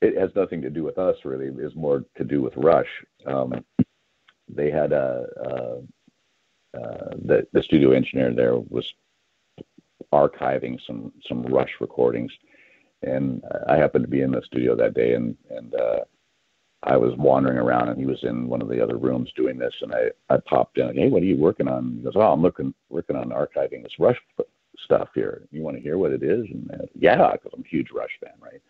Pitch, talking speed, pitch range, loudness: 65 Hz, 205 wpm, 60-70 Hz, -23 LUFS